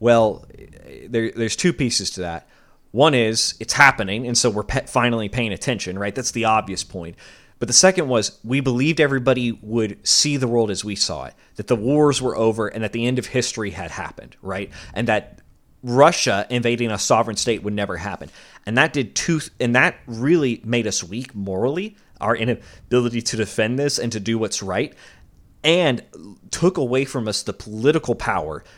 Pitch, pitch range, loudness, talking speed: 115 Hz, 105-130 Hz, -20 LUFS, 185 wpm